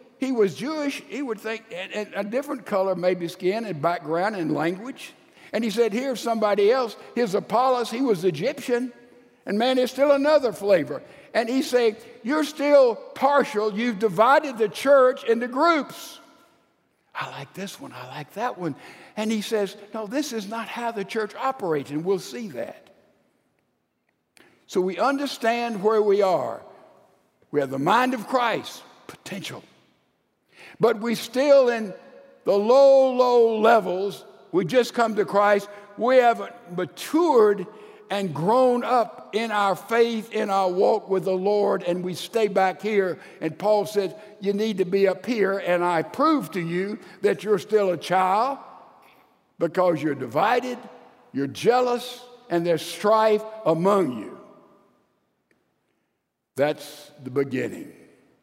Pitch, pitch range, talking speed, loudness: 220 Hz, 190-245 Hz, 150 wpm, -23 LUFS